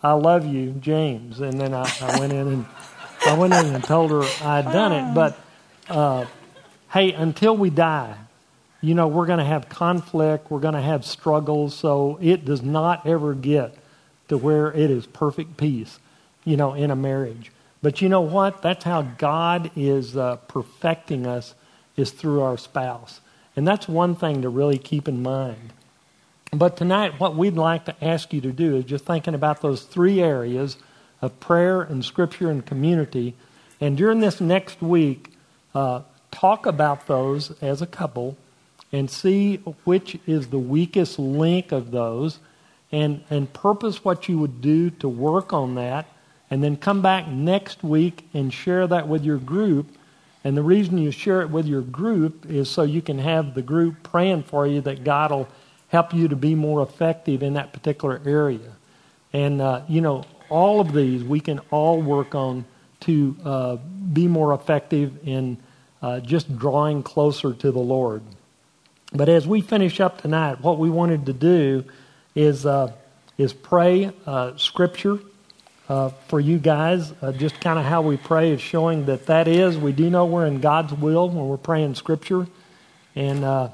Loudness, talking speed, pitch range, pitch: -22 LUFS, 180 wpm, 135-170 Hz, 150 Hz